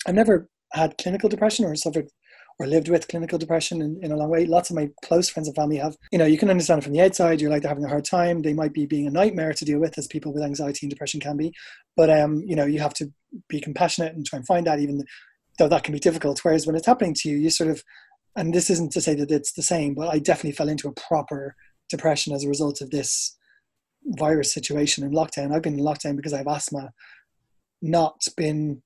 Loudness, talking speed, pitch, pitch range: -23 LUFS, 255 wpm, 155 Hz, 150-170 Hz